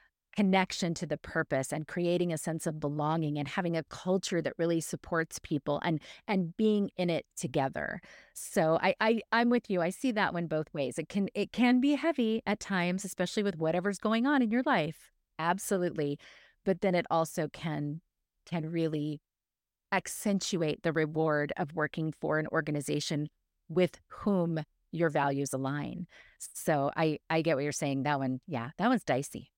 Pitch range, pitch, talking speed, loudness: 150-190 Hz, 165 Hz, 175 wpm, -31 LUFS